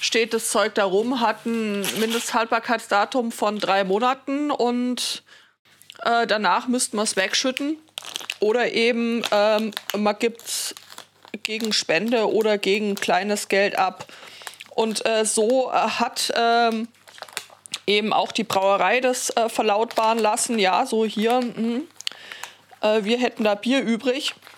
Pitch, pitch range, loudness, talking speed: 225 Hz, 210-240 Hz, -22 LUFS, 130 wpm